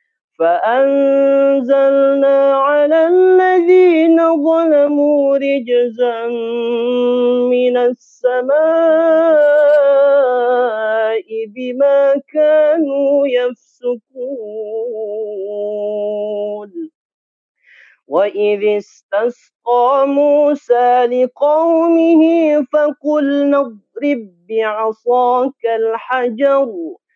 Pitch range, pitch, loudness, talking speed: 235-295 Hz, 275 Hz, -14 LUFS, 40 wpm